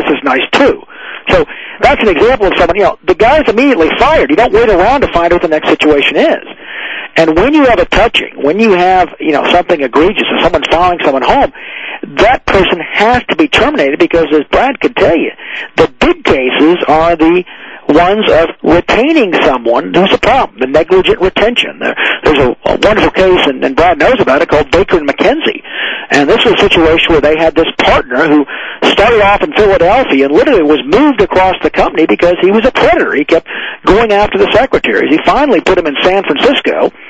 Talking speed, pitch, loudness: 205 wpm, 180 Hz, -8 LUFS